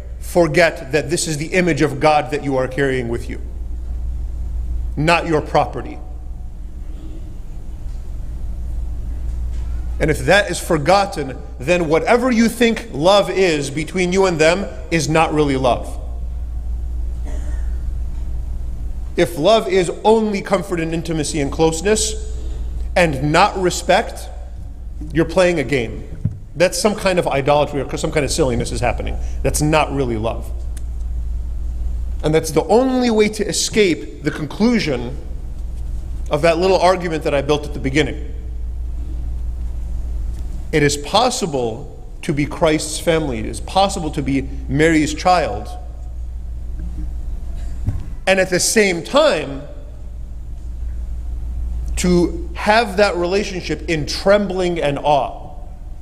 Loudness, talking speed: -18 LUFS, 120 wpm